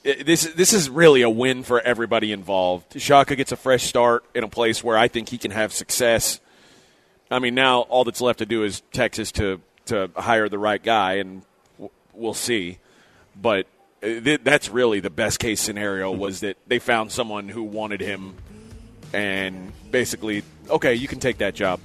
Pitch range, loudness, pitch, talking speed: 100-125 Hz, -21 LUFS, 110 Hz, 185 wpm